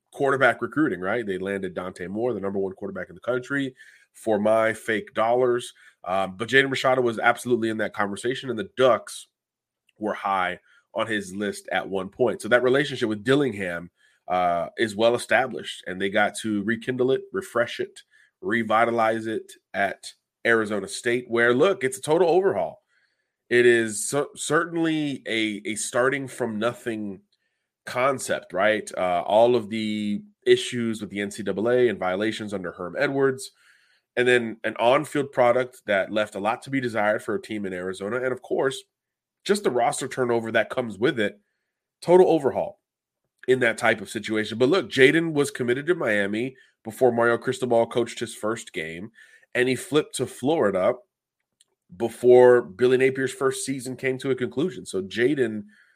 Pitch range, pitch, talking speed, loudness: 110-130 Hz, 120 Hz, 165 wpm, -24 LUFS